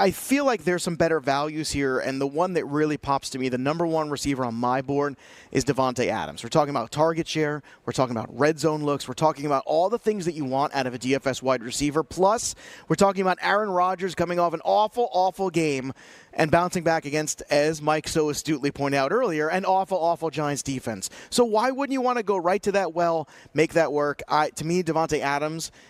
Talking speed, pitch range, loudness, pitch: 230 wpm, 140-175 Hz, -24 LUFS, 155 Hz